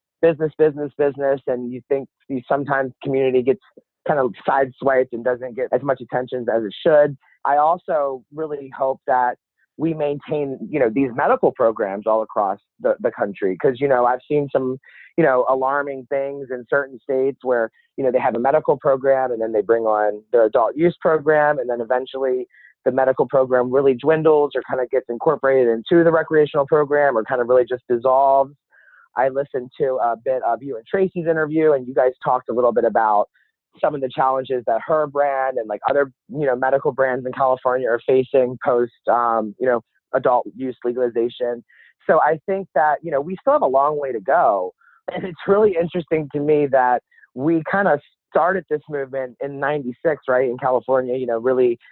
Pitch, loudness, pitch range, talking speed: 135 Hz, -20 LUFS, 125-150 Hz, 195 wpm